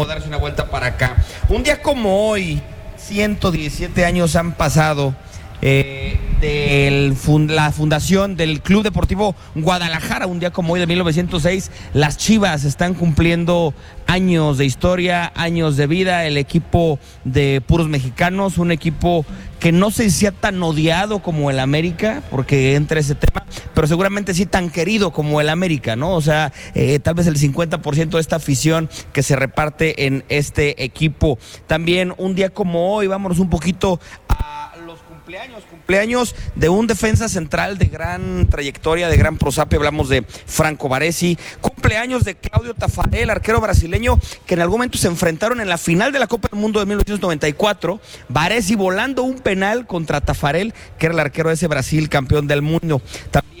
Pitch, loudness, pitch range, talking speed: 165 Hz, -17 LUFS, 145-185 Hz, 165 wpm